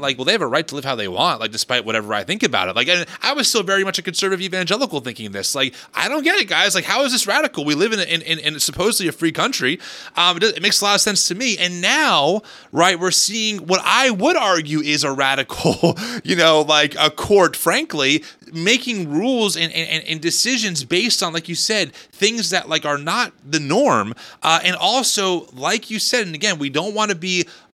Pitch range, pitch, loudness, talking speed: 155-215 Hz, 180 Hz, -17 LUFS, 240 wpm